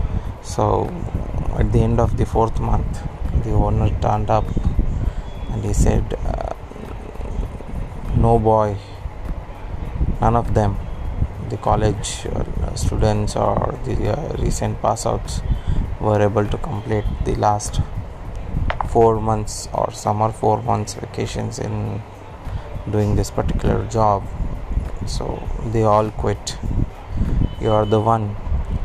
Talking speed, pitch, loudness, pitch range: 115 wpm, 105 Hz, -21 LUFS, 95-110 Hz